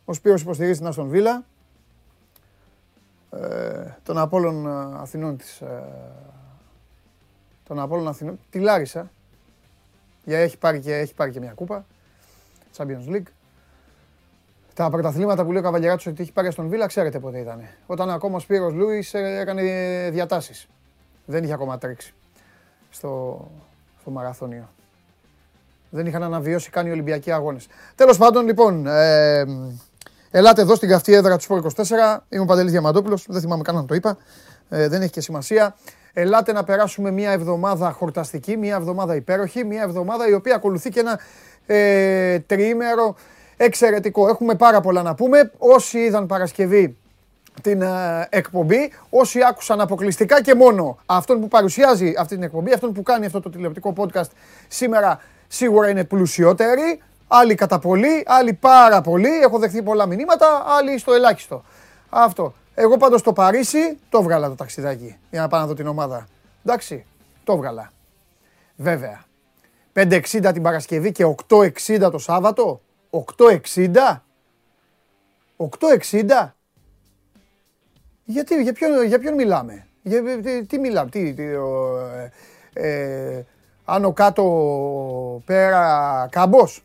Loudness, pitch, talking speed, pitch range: -18 LUFS, 180 Hz, 140 wpm, 140-210 Hz